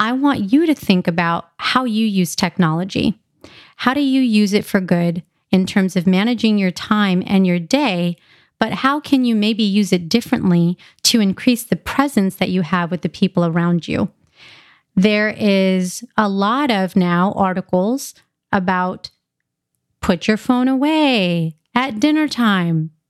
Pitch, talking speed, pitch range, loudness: 200 Hz, 160 wpm, 180-240 Hz, -17 LUFS